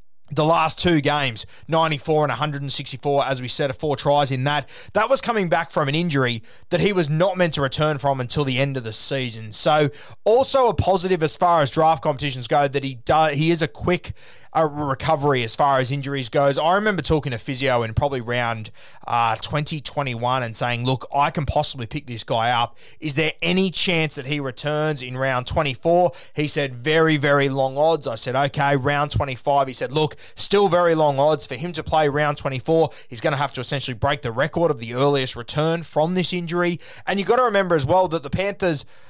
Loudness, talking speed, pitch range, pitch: -21 LUFS, 215 wpm, 130-160 Hz, 145 Hz